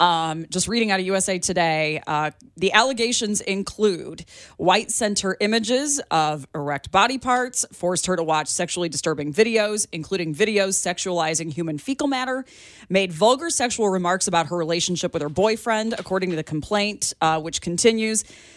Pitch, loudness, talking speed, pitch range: 190 Hz, -22 LUFS, 155 wpm, 165-220 Hz